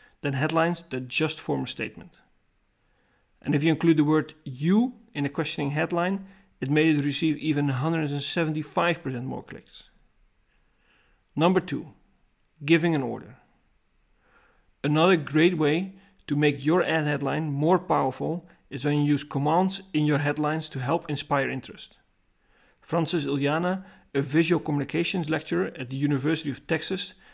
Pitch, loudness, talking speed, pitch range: 155 Hz, -26 LUFS, 140 wpm, 145-170 Hz